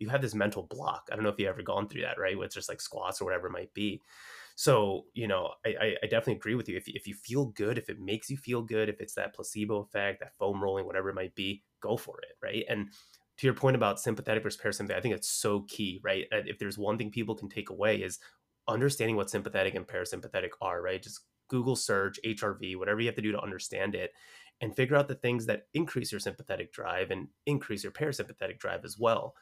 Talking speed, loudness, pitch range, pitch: 245 wpm, -33 LUFS, 100-130 Hz, 110 Hz